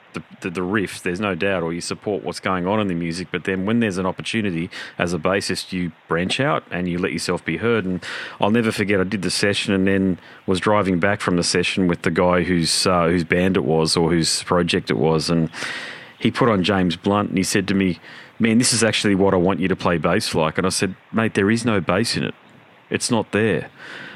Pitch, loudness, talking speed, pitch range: 95 Hz, -20 LUFS, 250 wpm, 90-100 Hz